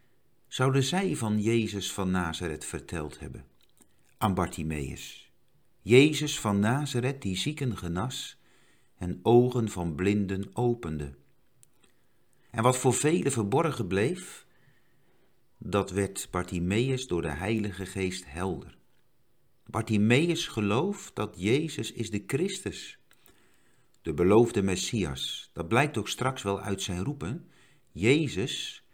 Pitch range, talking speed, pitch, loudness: 95-125 Hz, 110 wpm, 105 Hz, -28 LUFS